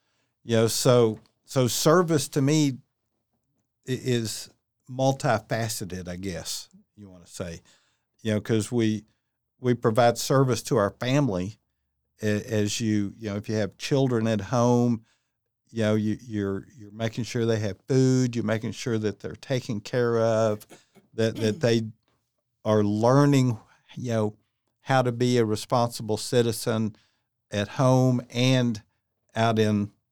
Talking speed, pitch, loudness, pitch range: 140 wpm, 115 Hz, -25 LUFS, 110-125 Hz